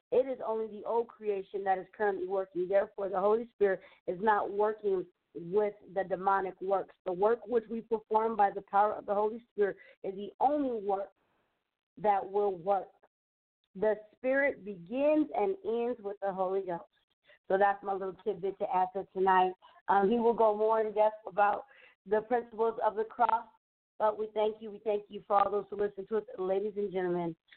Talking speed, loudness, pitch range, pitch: 190 wpm, -32 LUFS, 195-220 Hz, 205 Hz